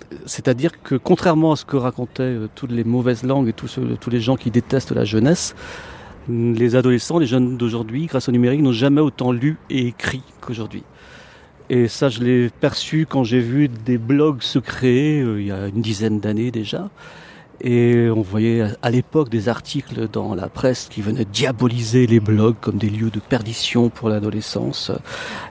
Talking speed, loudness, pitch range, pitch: 185 wpm, -19 LUFS, 115-135 Hz, 125 Hz